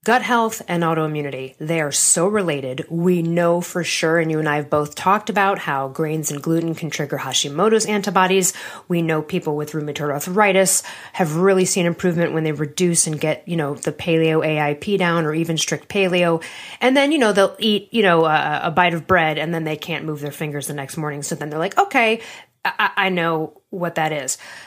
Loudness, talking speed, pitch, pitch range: -19 LUFS, 210 wpm, 165 Hz, 155-190 Hz